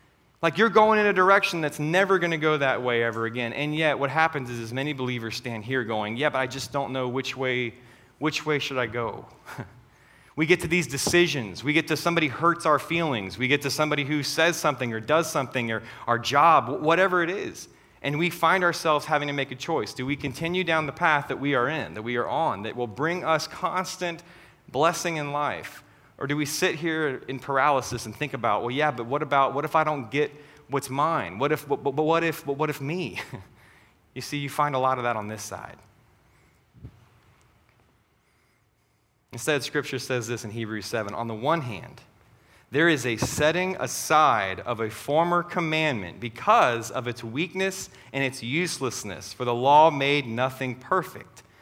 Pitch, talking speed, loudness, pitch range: 140 Hz, 200 wpm, -25 LUFS, 120-155 Hz